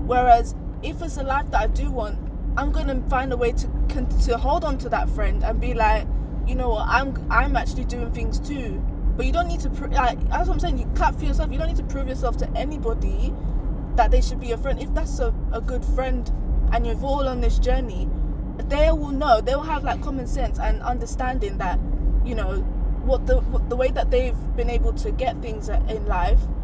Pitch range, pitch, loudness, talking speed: 245-310 Hz, 260 Hz, -24 LUFS, 230 wpm